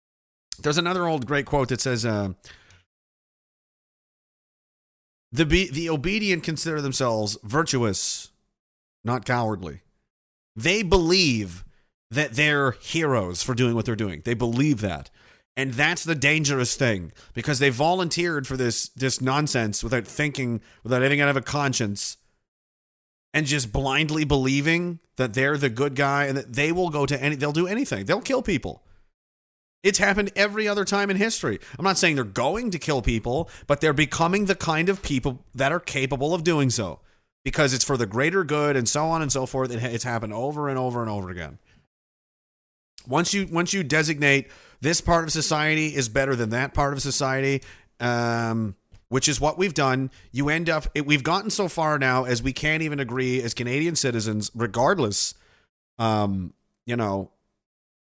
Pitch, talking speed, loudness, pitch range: 135 Hz, 170 wpm, -23 LUFS, 115-155 Hz